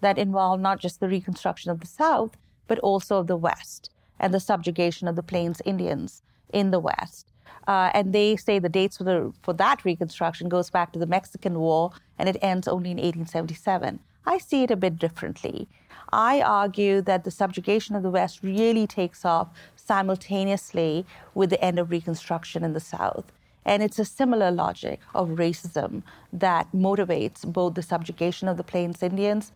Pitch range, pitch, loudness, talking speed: 175-195 Hz, 185 Hz, -25 LUFS, 180 wpm